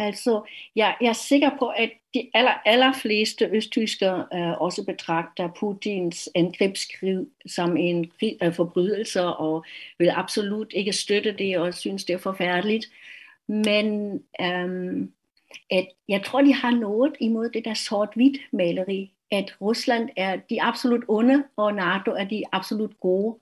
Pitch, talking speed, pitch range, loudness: 210 Hz, 140 wpm, 185-225 Hz, -24 LUFS